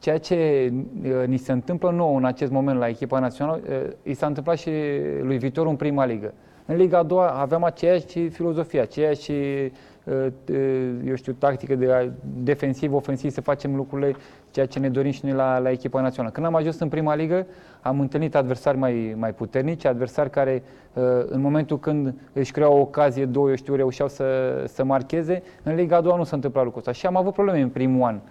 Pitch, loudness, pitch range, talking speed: 140 Hz, -23 LUFS, 130-155 Hz, 195 wpm